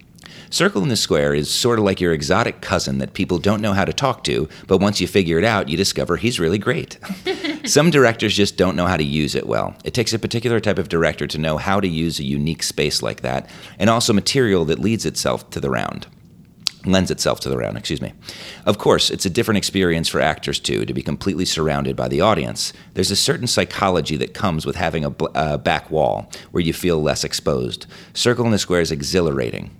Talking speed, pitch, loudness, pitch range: 225 wpm, 95 Hz, -19 LUFS, 80-110 Hz